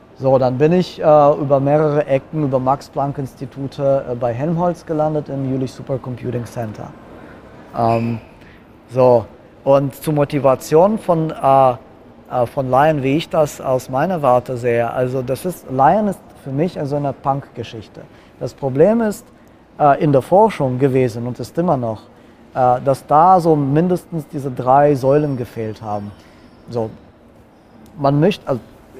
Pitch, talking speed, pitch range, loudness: 135 Hz, 150 wpm, 125-150 Hz, -17 LUFS